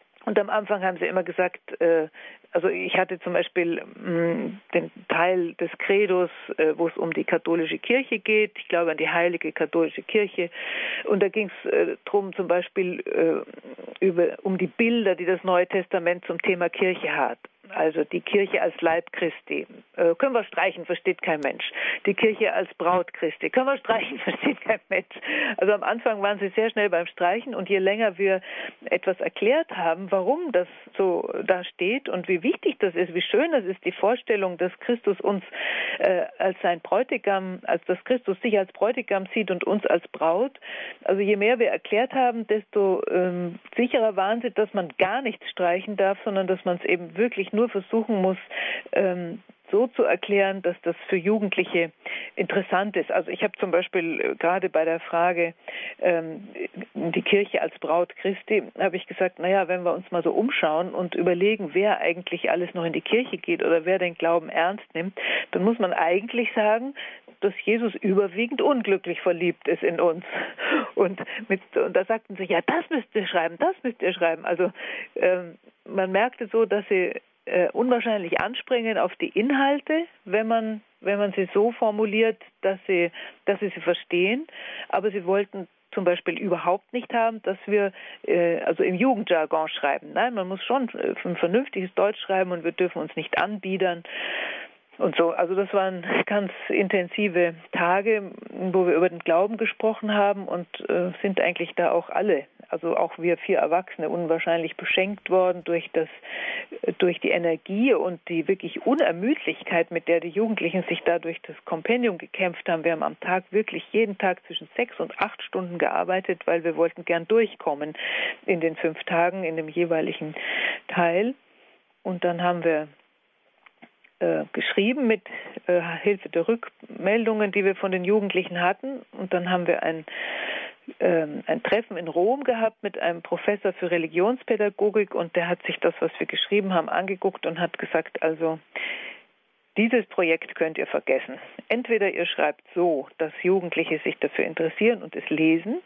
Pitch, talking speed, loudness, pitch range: 190 Hz, 170 wpm, -25 LUFS, 175-220 Hz